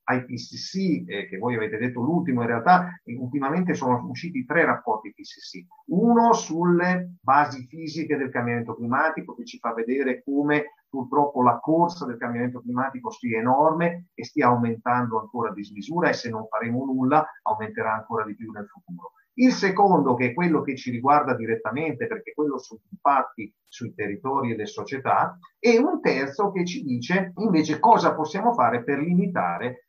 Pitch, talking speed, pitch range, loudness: 140 Hz, 170 wpm, 120-175 Hz, -24 LUFS